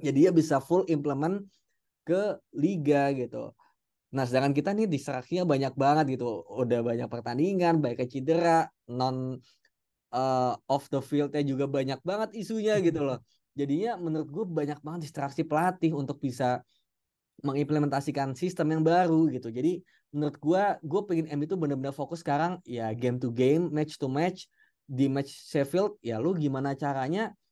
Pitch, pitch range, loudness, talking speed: 145 Hz, 135-170 Hz, -29 LUFS, 155 wpm